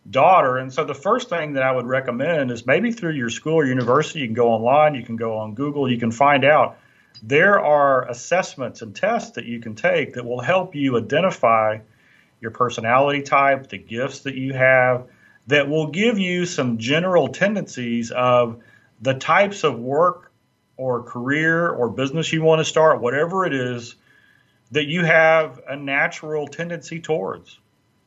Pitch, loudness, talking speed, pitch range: 135 Hz, -19 LUFS, 175 wpm, 120-160 Hz